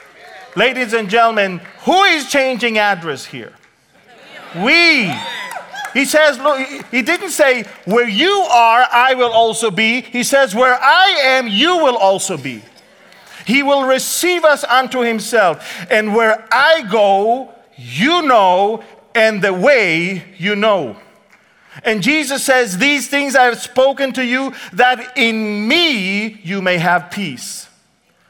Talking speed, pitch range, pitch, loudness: 140 wpm, 210-275 Hz, 245 Hz, -13 LUFS